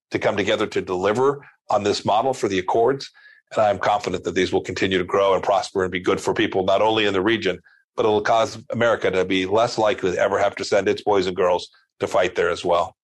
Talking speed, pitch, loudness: 260 wpm, 115 Hz, -21 LUFS